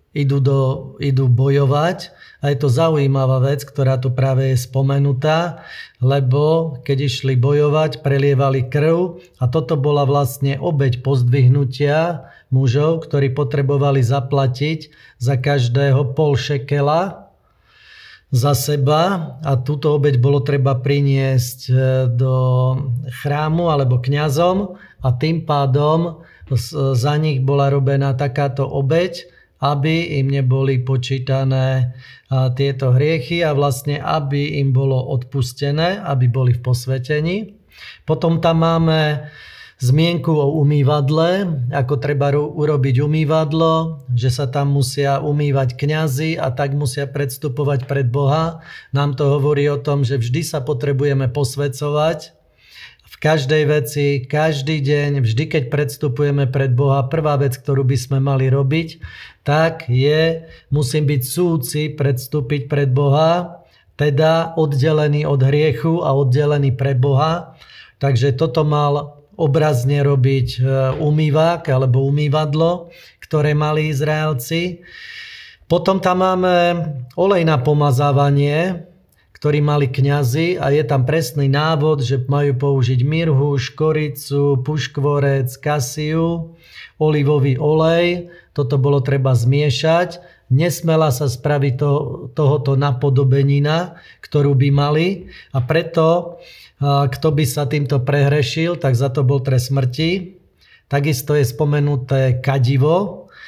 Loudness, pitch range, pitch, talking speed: -17 LUFS, 135-155 Hz, 145 Hz, 115 wpm